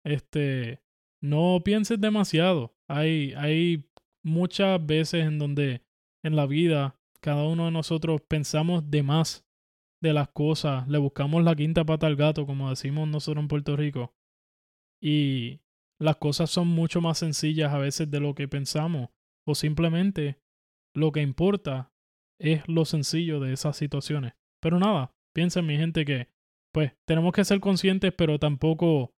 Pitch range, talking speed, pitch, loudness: 140-165 Hz, 150 wpm, 150 Hz, -26 LUFS